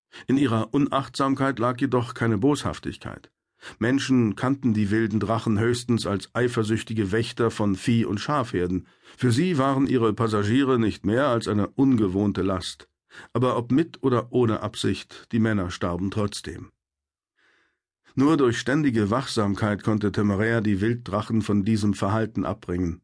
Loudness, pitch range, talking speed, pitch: -24 LUFS, 100-125 Hz, 140 wpm, 110 Hz